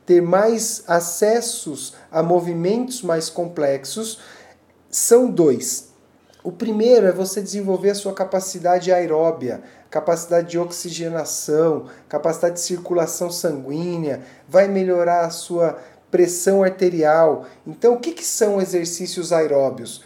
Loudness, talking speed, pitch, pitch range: -19 LUFS, 110 wpm, 175 Hz, 165-195 Hz